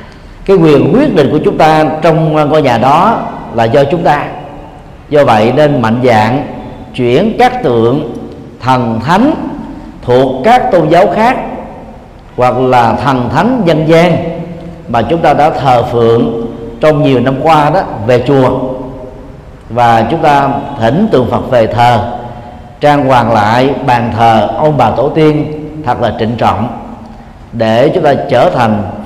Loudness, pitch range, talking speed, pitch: -9 LUFS, 120-155 Hz, 155 wpm, 130 Hz